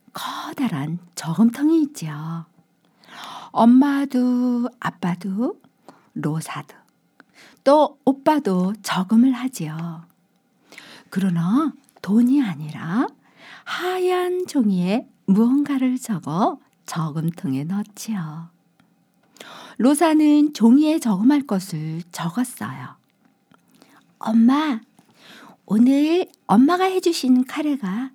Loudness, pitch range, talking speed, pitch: -20 LUFS, 185-280 Hz, 175 characters per minute, 245 Hz